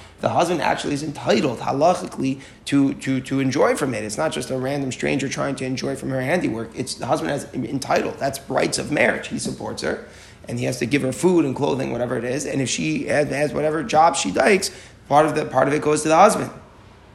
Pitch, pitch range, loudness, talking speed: 135 Hz, 130-150 Hz, -21 LUFS, 230 wpm